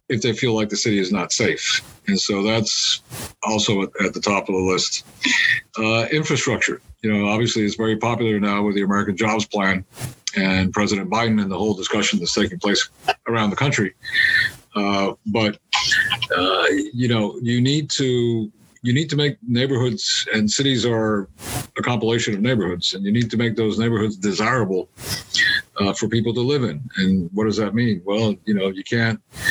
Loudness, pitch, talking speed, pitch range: -20 LUFS, 110 Hz, 185 wpm, 105-120 Hz